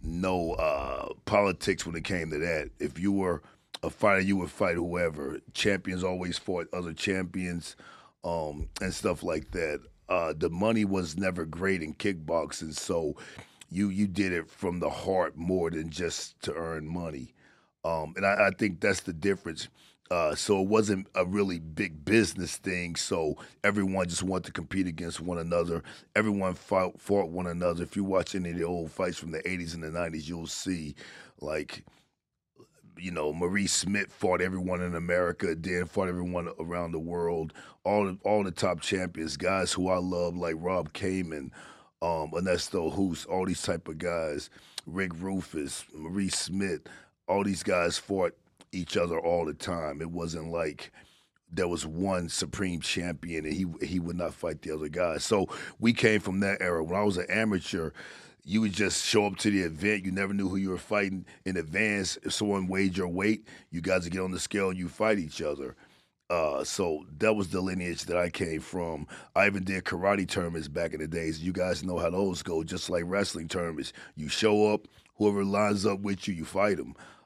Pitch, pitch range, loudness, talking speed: 90 Hz, 85-100 Hz, -30 LUFS, 190 wpm